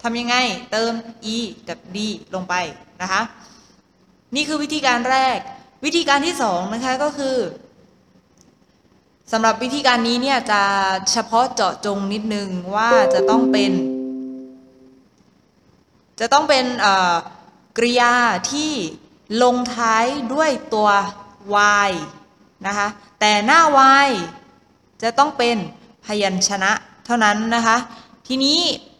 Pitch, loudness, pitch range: 225 Hz, -18 LUFS, 200-255 Hz